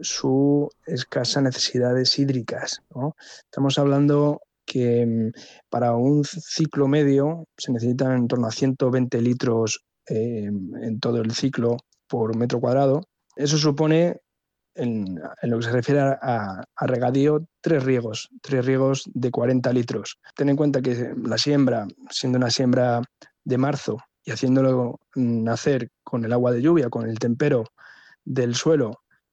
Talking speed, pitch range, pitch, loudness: 140 wpm, 120-140 Hz, 130 Hz, -23 LUFS